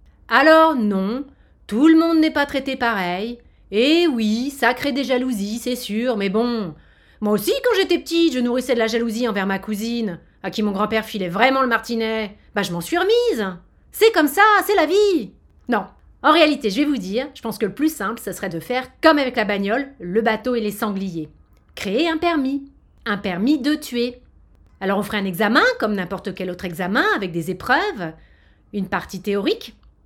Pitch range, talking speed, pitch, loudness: 205-285 Hz, 200 wpm, 230 Hz, -20 LUFS